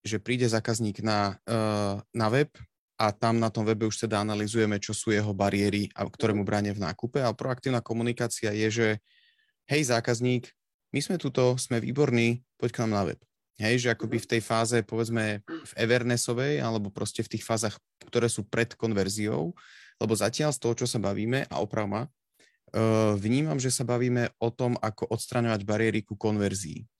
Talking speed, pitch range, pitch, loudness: 180 wpm, 105-120 Hz, 115 Hz, -28 LUFS